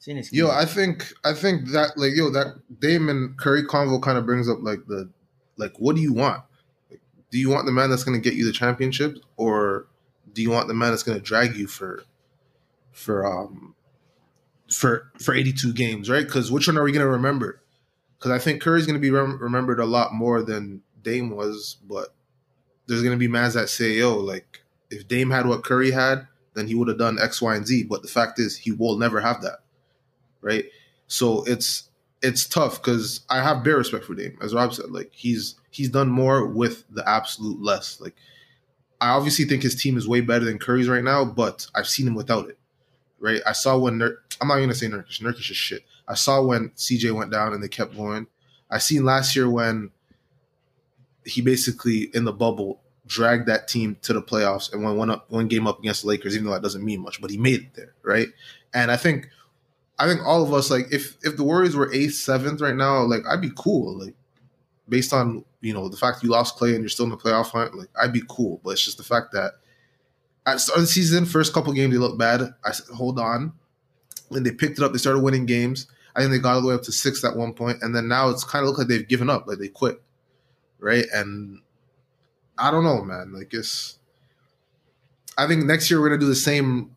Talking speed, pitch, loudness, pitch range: 230 wpm, 125 Hz, -22 LUFS, 115-135 Hz